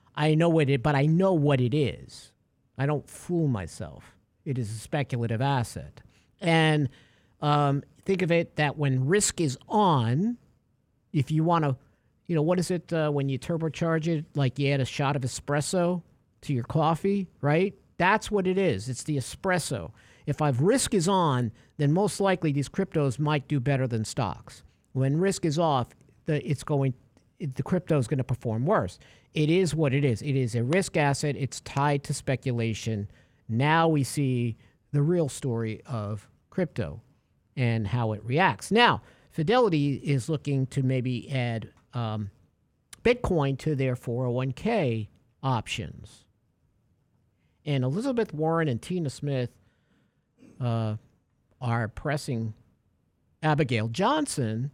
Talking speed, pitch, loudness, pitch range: 155 wpm, 140 Hz, -27 LUFS, 120-160 Hz